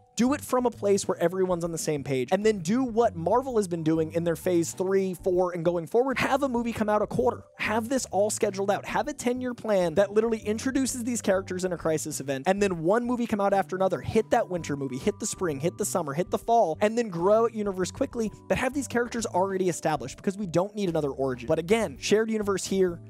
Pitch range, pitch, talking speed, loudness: 175-230 Hz, 200 Hz, 250 wpm, -27 LUFS